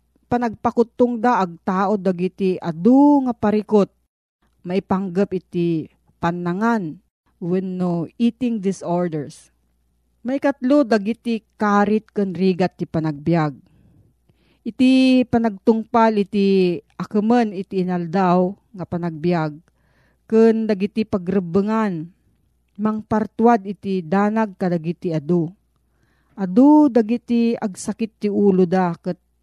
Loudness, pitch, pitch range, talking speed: -19 LUFS, 200 Hz, 175-225 Hz, 95 wpm